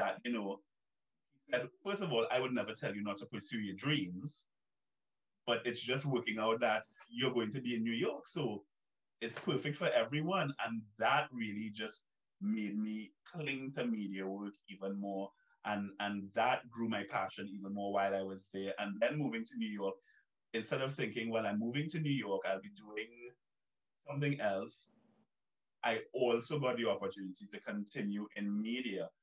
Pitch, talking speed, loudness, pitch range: 115 Hz, 180 wpm, -38 LUFS, 100-130 Hz